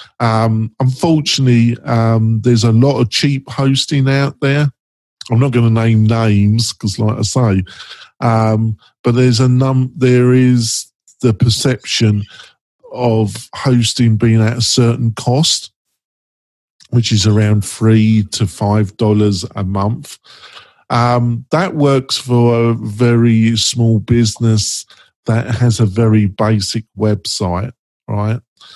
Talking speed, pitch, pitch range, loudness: 125 wpm, 115 Hz, 110-125 Hz, -14 LUFS